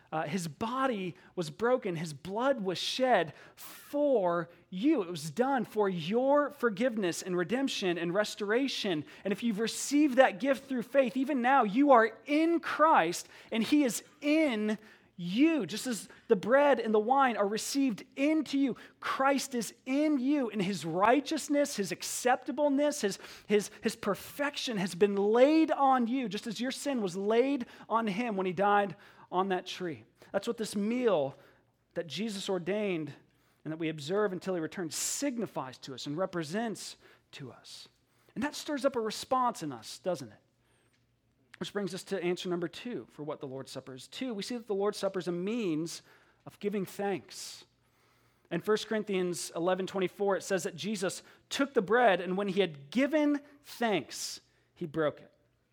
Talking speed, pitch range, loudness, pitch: 175 wpm, 175-260 Hz, -31 LUFS, 205 Hz